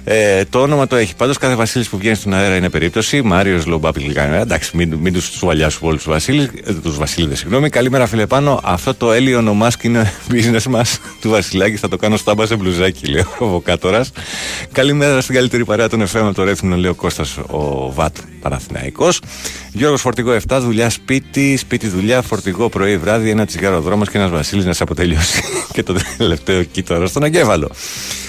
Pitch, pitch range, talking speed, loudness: 105 Hz, 90-120 Hz, 195 wpm, -15 LUFS